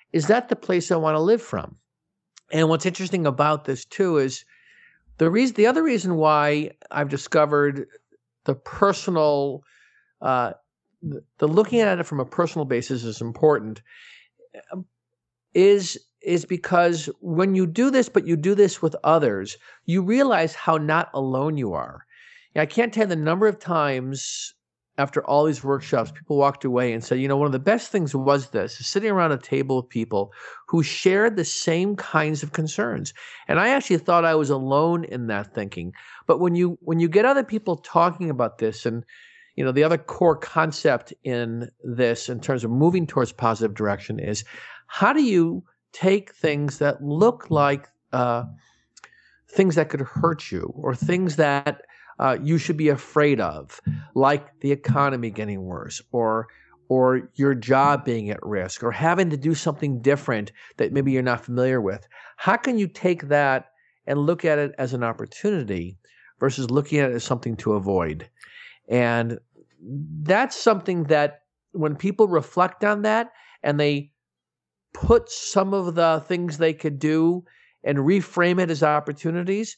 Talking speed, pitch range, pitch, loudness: 170 wpm, 130-180 Hz, 150 Hz, -22 LUFS